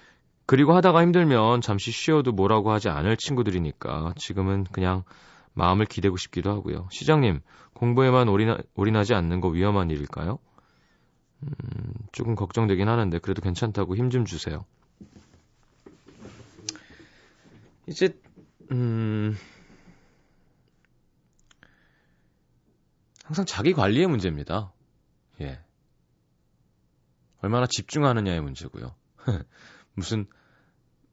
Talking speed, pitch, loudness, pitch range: 235 characters per minute, 105 Hz, -24 LUFS, 95-125 Hz